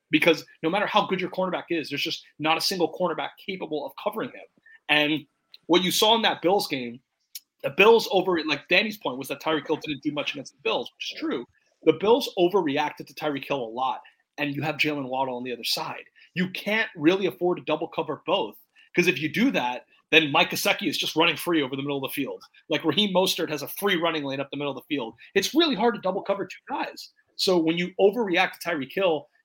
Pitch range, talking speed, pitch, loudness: 150-195 Hz, 240 wpm, 165 Hz, -25 LUFS